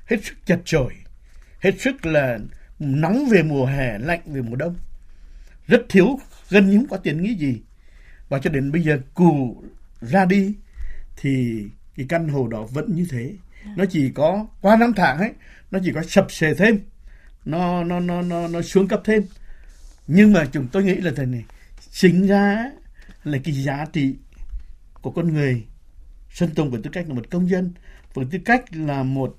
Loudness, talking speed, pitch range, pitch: -20 LUFS, 190 wpm, 130-190 Hz, 160 Hz